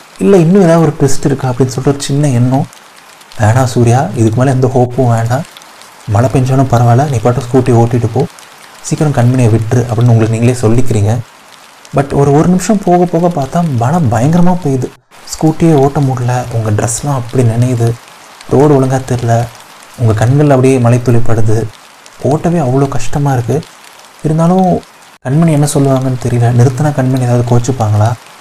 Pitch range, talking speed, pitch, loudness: 120-145 Hz, 150 wpm, 130 Hz, -11 LUFS